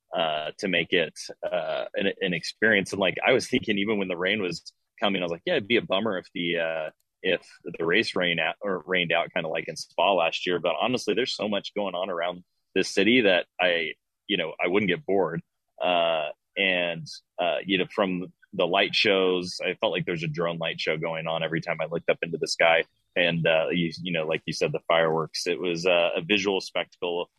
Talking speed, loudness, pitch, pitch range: 230 wpm, -26 LUFS, 85 Hz, 80-90 Hz